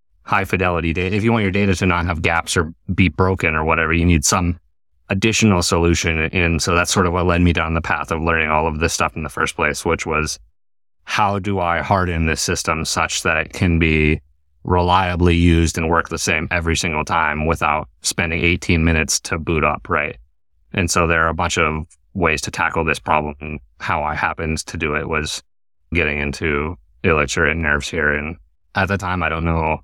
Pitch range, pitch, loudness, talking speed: 75-90 Hz, 85 Hz, -18 LUFS, 210 wpm